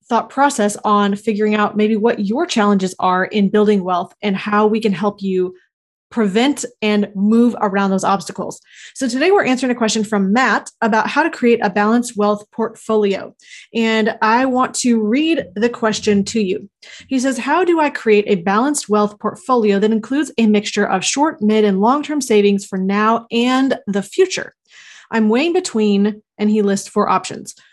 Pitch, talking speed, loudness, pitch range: 215 Hz, 180 wpm, -16 LUFS, 205-245 Hz